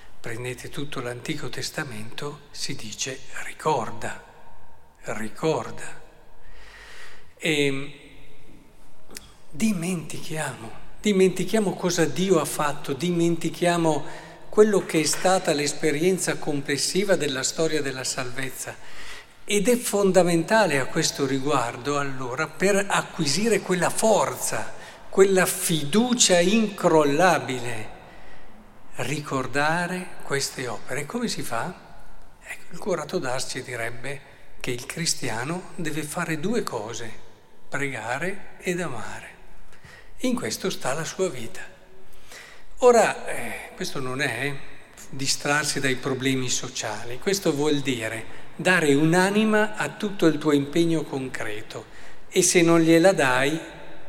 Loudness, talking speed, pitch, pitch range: -24 LUFS, 100 wpm, 155 Hz, 135-185 Hz